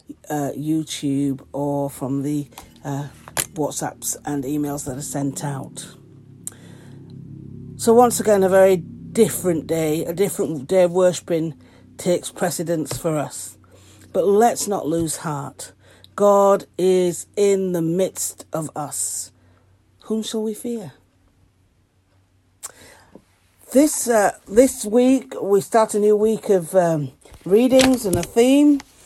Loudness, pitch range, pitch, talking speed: -20 LUFS, 130-200 Hz, 155 Hz, 125 wpm